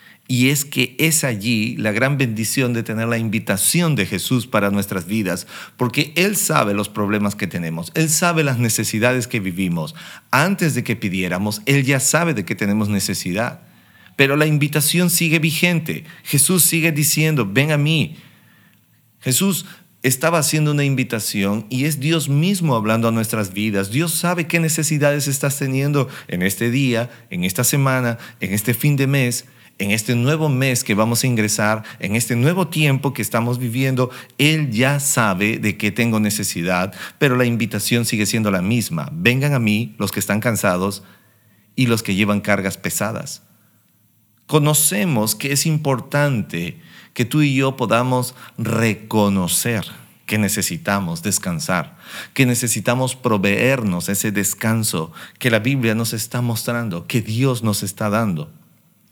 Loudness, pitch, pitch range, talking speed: -18 LUFS, 120 Hz, 105-145 Hz, 155 wpm